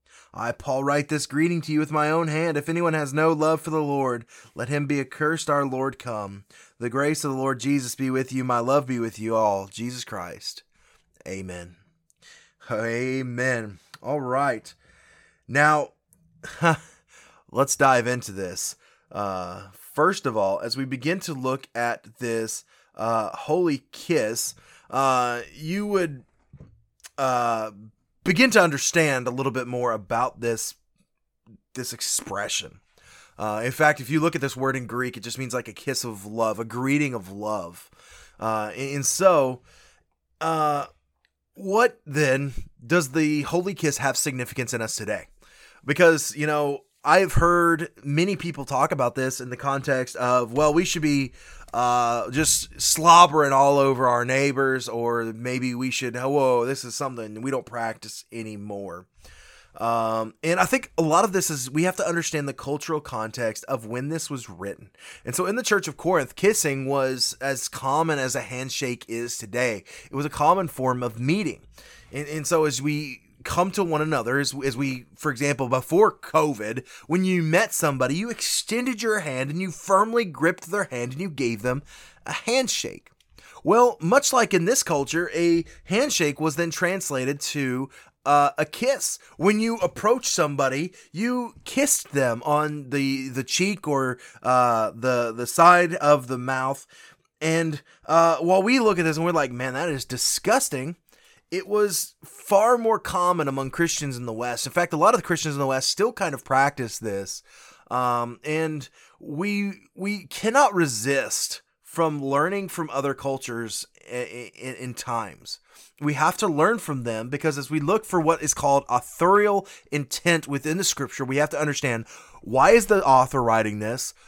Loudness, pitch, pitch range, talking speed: -23 LUFS, 140 Hz, 125-165 Hz, 170 wpm